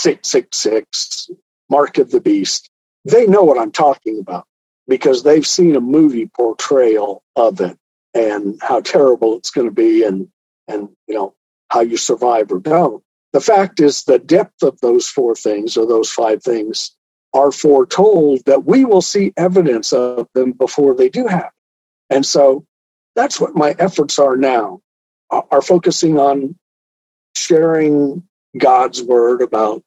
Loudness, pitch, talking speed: -14 LUFS, 150 Hz, 155 wpm